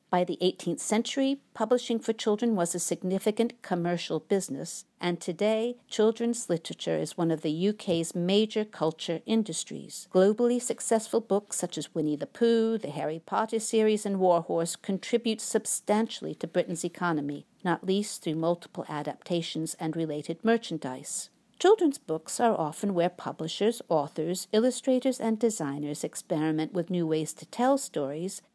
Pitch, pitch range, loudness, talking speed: 185 Hz, 165-225 Hz, -29 LUFS, 145 wpm